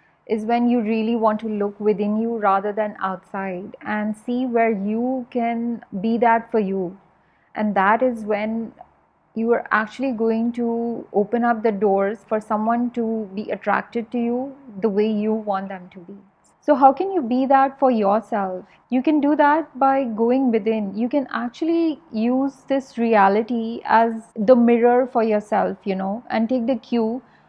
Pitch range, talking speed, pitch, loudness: 210-245 Hz, 175 wpm, 230 Hz, -21 LUFS